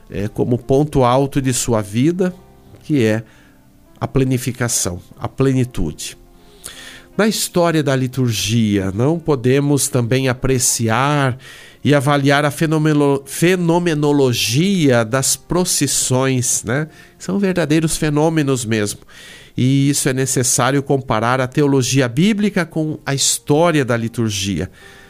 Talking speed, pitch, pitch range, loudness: 110 wpm, 135 Hz, 120-155 Hz, -16 LUFS